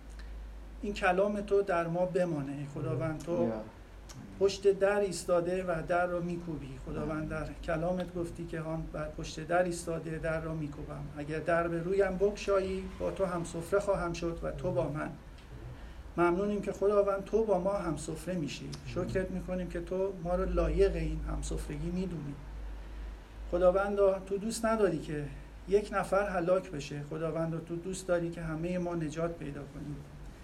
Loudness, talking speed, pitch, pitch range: -33 LUFS, 165 wpm, 170 Hz, 155-190 Hz